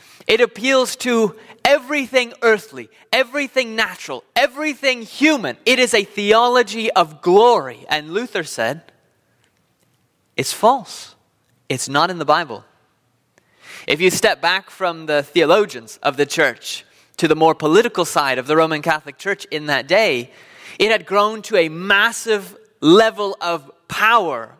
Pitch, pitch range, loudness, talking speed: 215 Hz, 165-255 Hz, -17 LUFS, 140 wpm